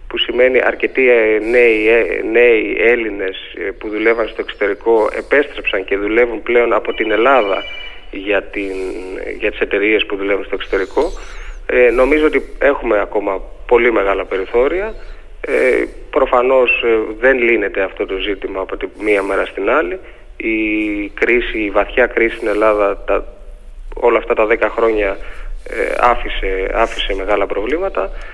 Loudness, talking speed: -15 LUFS, 140 wpm